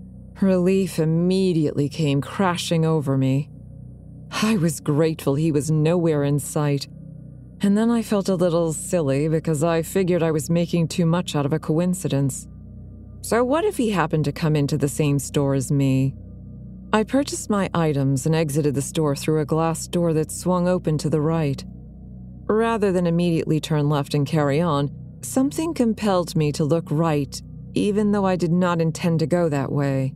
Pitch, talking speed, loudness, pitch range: 160 Hz, 175 wpm, -22 LUFS, 145-175 Hz